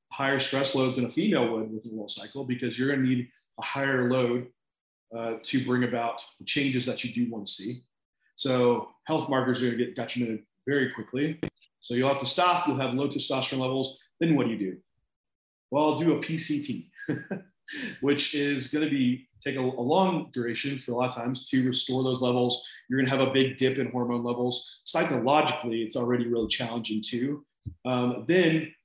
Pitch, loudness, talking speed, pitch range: 130 Hz, -28 LUFS, 205 wpm, 120-140 Hz